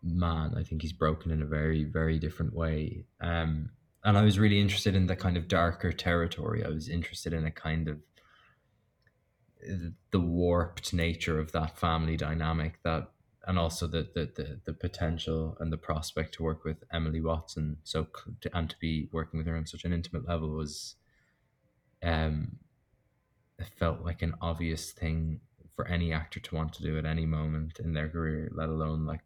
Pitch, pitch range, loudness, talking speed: 80 Hz, 80-90 Hz, -32 LUFS, 185 wpm